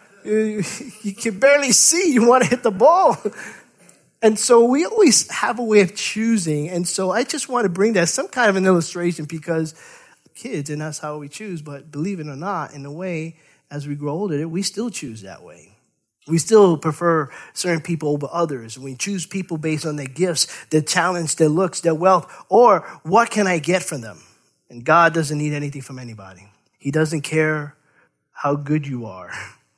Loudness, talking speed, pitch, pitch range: -19 LUFS, 195 wpm, 170 Hz, 150-205 Hz